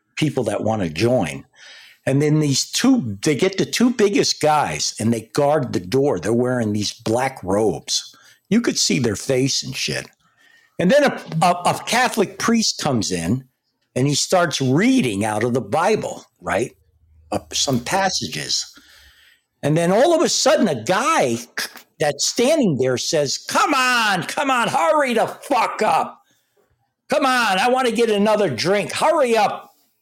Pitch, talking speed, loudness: 150 Hz, 165 wpm, -19 LUFS